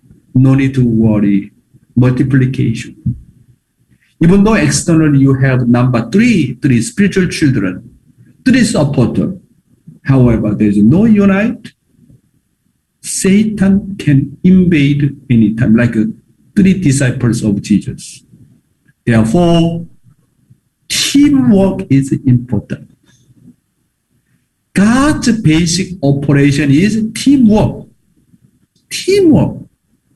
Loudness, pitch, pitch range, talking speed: -11 LUFS, 145 Hz, 125-195 Hz, 80 wpm